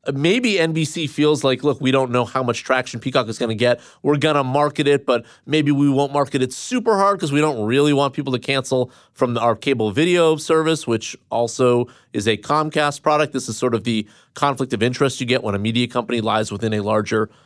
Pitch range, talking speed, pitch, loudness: 120-145 Hz, 225 wpm, 130 Hz, -19 LUFS